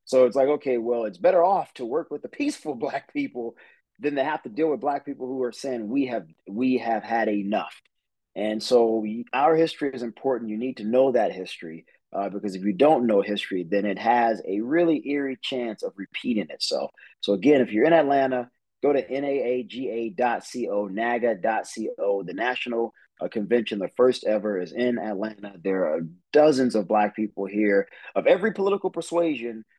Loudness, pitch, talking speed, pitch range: -25 LUFS, 120 Hz, 185 wpm, 105-140 Hz